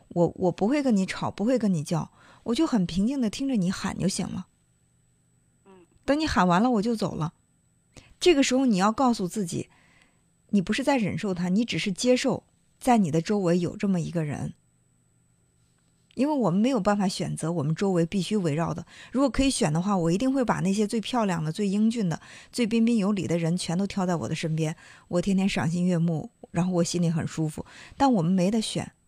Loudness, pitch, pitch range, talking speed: -26 LUFS, 190 Hz, 165-230 Hz, 300 characters per minute